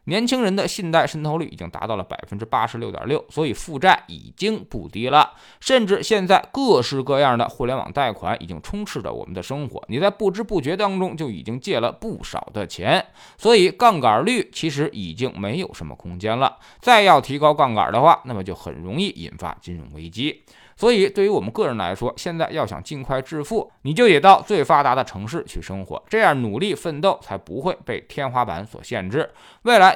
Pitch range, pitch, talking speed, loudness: 120-205 Hz, 155 Hz, 315 characters per minute, -20 LUFS